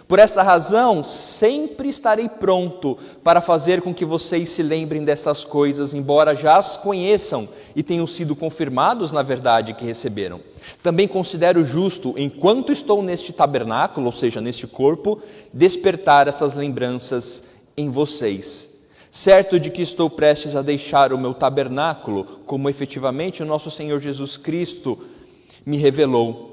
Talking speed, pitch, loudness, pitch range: 140 wpm, 155 Hz, -19 LUFS, 140-180 Hz